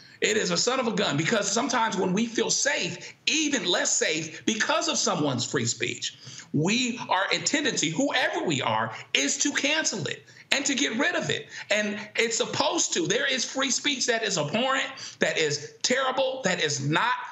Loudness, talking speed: -25 LUFS, 190 wpm